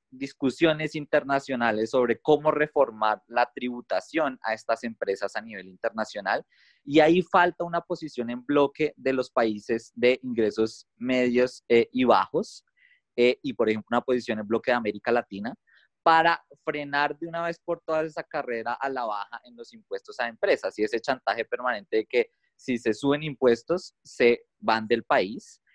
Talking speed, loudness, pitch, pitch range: 165 wpm, -26 LUFS, 130 Hz, 115-160 Hz